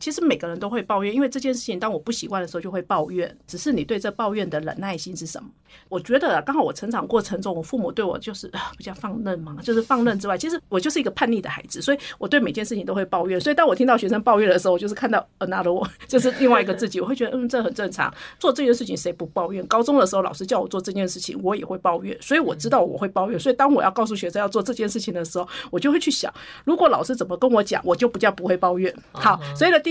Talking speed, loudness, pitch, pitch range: 445 characters per minute, -22 LUFS, 215 Hz, 185-255 Hz